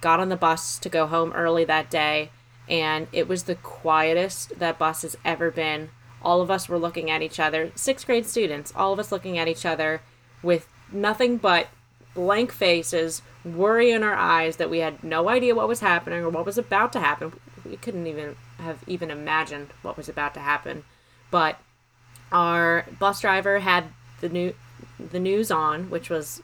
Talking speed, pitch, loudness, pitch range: 190 wpm, 165 Hz, -24 LUFS, 155-180 Hz